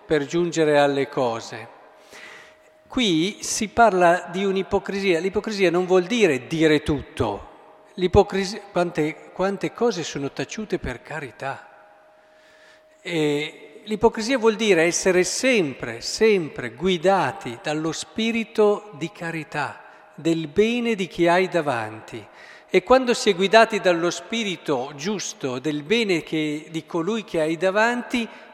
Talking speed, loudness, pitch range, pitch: 120 wpm, -22 LUFS, 155-210 Hz, 180 Hz